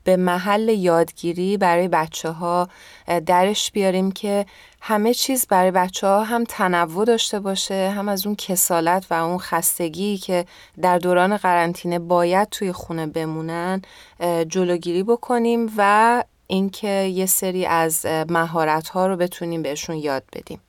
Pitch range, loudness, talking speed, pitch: 170-200 Hz, -20 LUFS, 135 wpm, 185 Hz